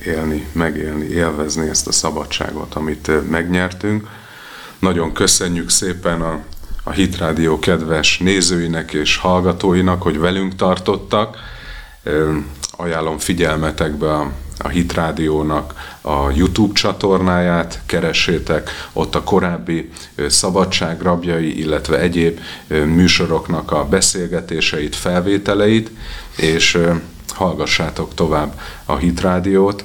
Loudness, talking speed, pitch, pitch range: -16 LUFS, 95 wpm, 85 Hz, 75-90 Hz